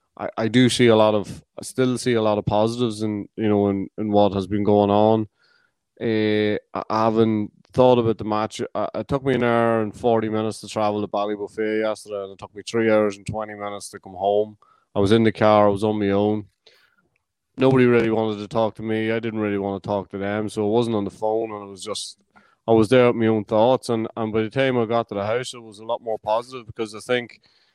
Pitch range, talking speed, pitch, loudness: 105-115 Hz, 255 wpm, 110 Hz, -21 LUFS